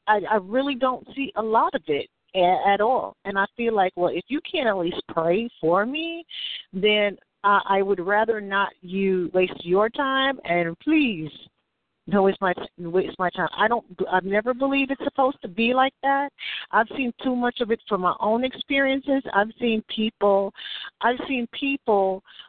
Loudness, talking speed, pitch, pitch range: -23 LUFS, 180 wpm, 215 Hz, 195-265 Hz